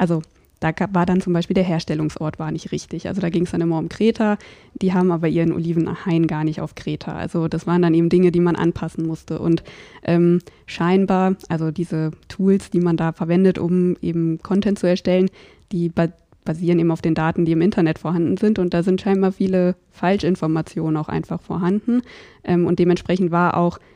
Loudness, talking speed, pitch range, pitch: -20 LUFS, 200 wpm, 165-185 Hz, 175 Hz